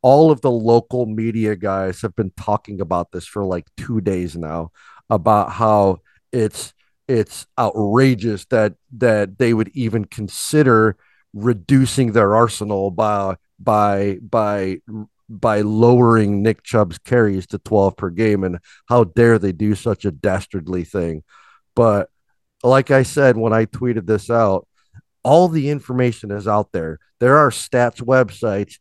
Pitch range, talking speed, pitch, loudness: 100-120 Hz, 145 wpm, 110 Hz, -17 LUFS